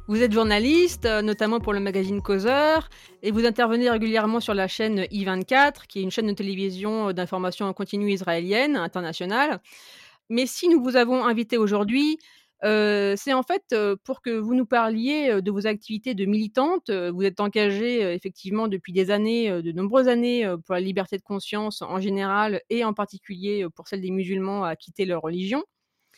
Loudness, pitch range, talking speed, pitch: -24 LUFS, 195-235 Hz, 175 wpm, 210 Hz